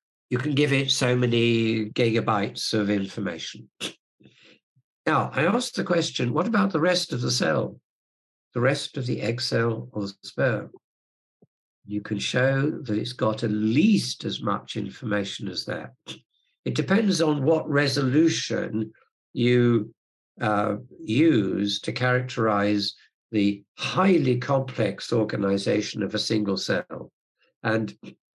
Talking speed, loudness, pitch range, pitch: 130 wpm, -25 LUFS, 105-135 Hz, 115 Hz